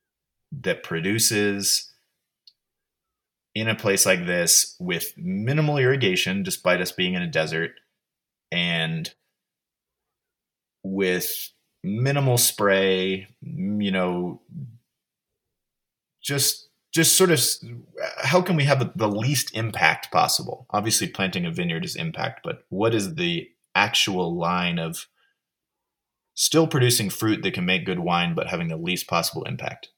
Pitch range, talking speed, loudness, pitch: 90-150 Hz, 120 wpm, -22 LUFS, 110 Hz